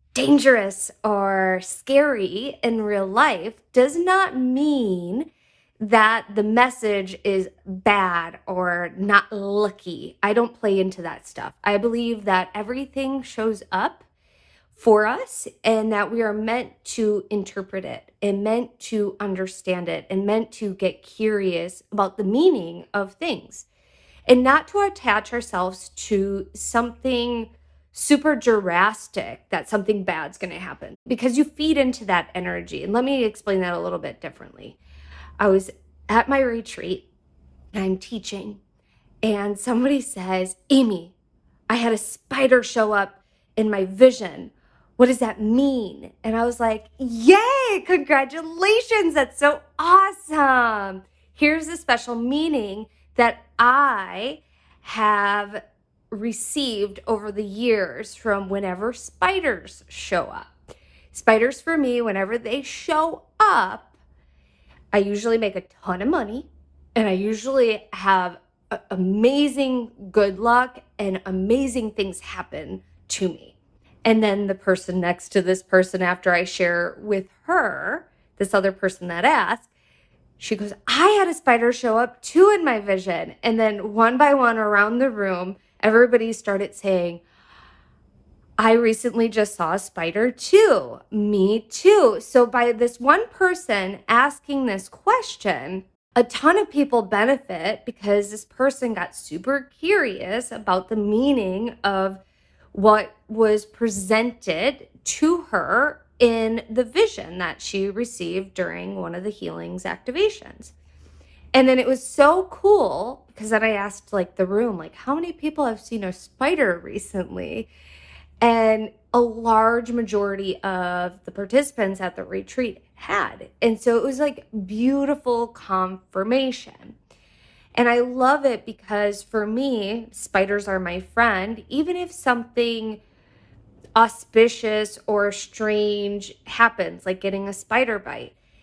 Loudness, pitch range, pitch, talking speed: -21 LUFS, 195-250 Hz, 220 Hz, 135 wpm